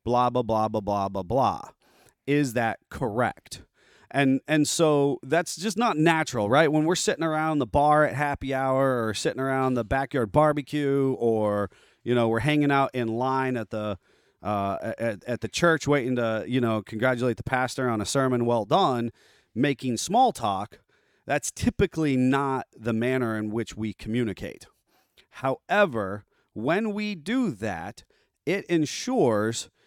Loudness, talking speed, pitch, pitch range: -25 LUFS, 160 wpm, 130 Hz, 115-150 Hz